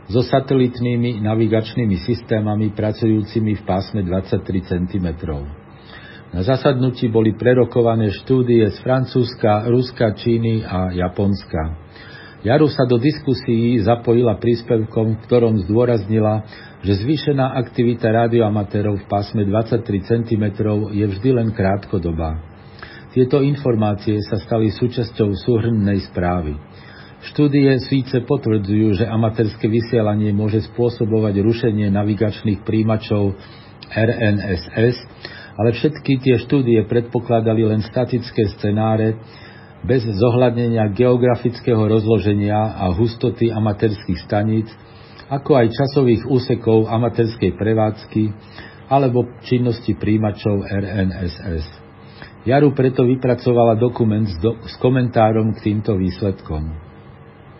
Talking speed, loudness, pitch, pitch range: 100 wpm, -18 LUFS, 110 Hz, 105-120 Hz